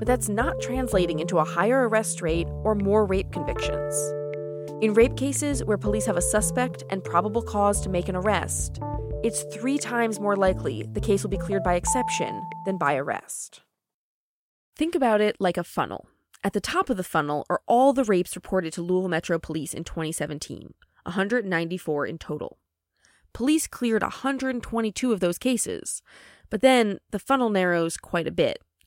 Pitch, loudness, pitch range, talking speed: 180 Hz, -25 LUFS, 150-220 Hz, 175 wpm